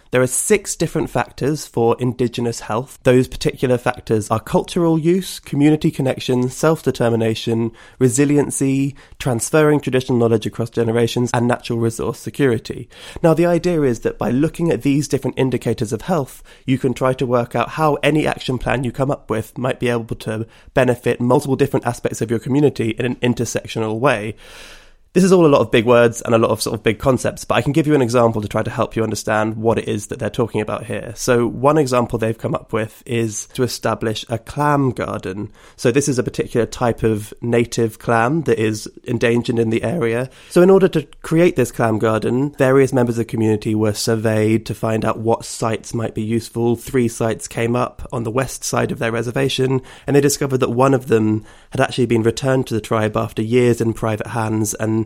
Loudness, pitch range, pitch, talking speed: -18 LUFS, 115-135 Hz, 120 Hz, 205 wpm